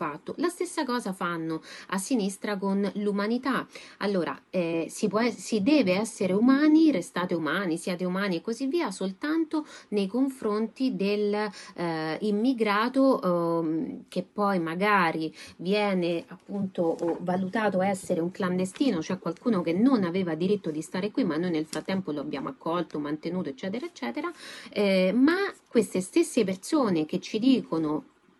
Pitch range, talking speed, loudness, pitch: 175-240 Hz, 140 wpm, -27 LUFS, 200 Hz